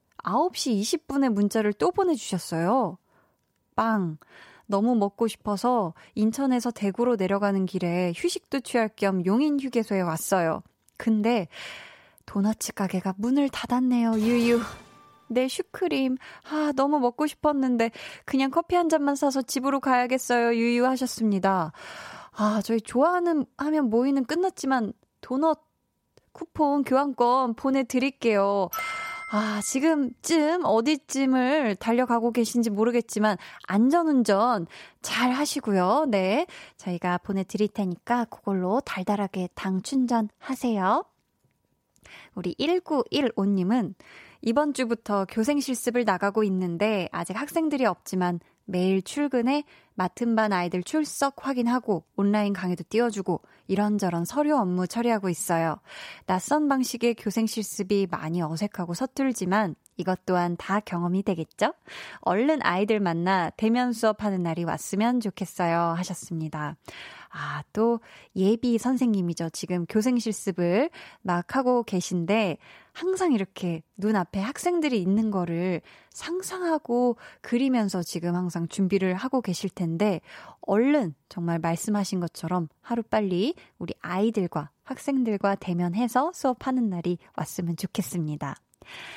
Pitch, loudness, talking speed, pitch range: 220 Hz, -26 LUFS, 280 characters per minute, 190-260 Hz